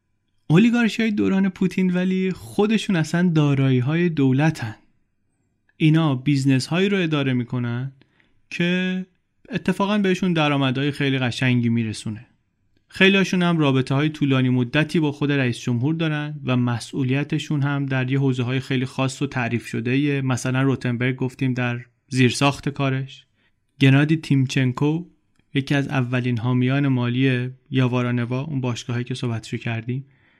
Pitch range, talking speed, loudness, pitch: 125-155 Hz, 130 wpm, -21 LUFS, 135 Hz